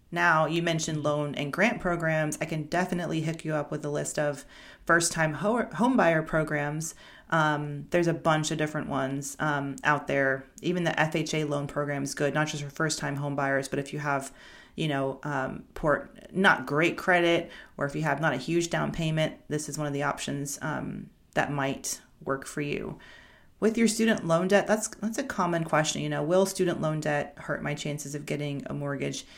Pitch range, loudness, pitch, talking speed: 145-170 Hz, -28 LUFS, 155 Hz, 205 wpm